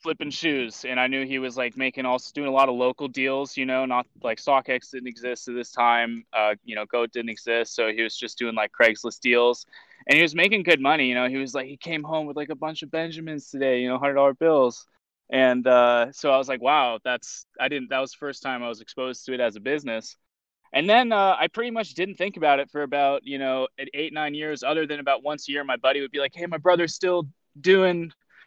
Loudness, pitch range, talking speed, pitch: -24 LUFS, 125-155 Hz, 260 wpm, 135 Hz